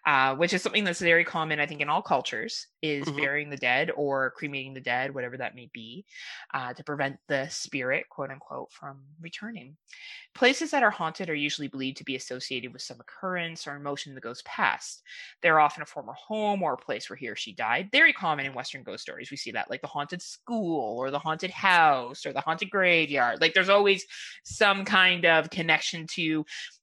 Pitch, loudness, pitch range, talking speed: 155 Hz, -26 LUFS, 135-180 Hz, 210 wpm